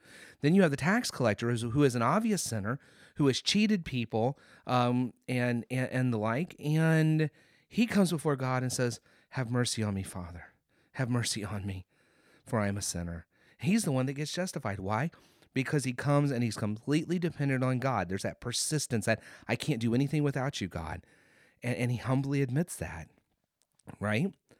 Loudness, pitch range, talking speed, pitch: -31 LUFS, 115-150 Hz, 190 wpm, 130 Hz